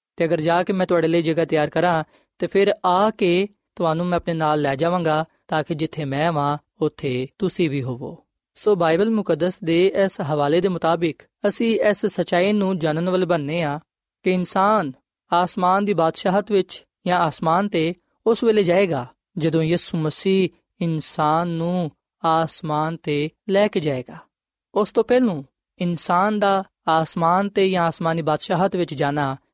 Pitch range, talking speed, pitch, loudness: 160-190 Hz, 165 wpm, 170 Hz, -21 LUFS